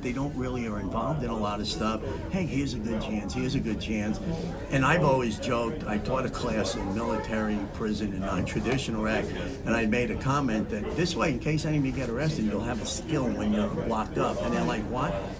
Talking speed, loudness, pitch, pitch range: 240 wpm, -29 LUFS, 110 Hz, 105-125 Hz